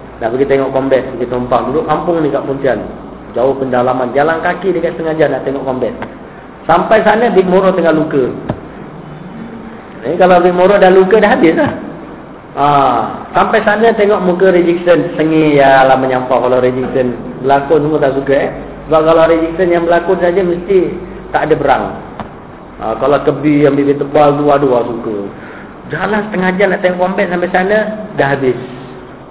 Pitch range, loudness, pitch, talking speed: 135-185 Hz, -11 LUFS, 160 Hz, 165 wpm